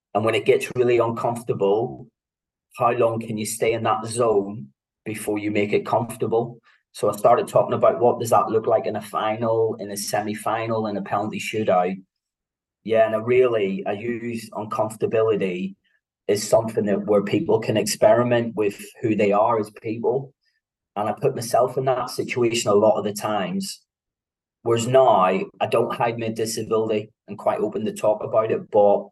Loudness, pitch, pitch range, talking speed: -22 LUFS, 115 Hz, 105-120 Hz, 180 wpm